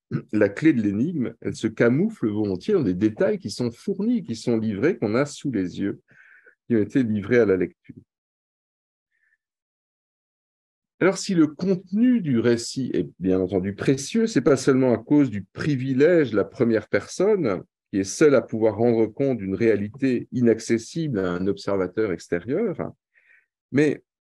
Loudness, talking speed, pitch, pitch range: -23 LUFS, 160 wpm, 120 Hz, 110-155 Hz